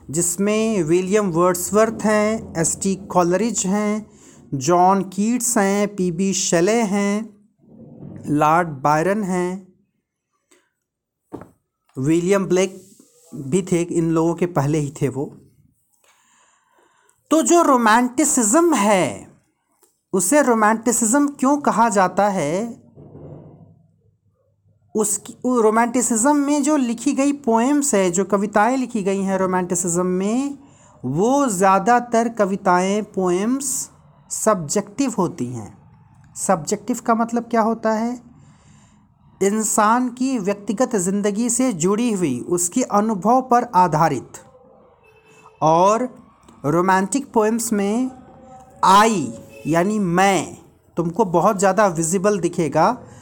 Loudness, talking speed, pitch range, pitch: -19 LUFS, 100 wpm, 180-235 Hz, 205 Hz